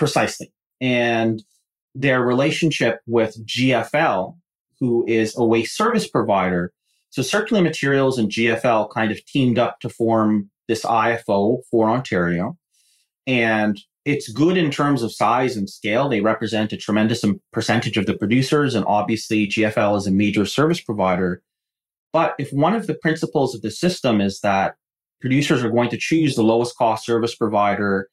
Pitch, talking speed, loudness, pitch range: 115 Hz, 155 wpm, -20 LUFS, 110-140 Hz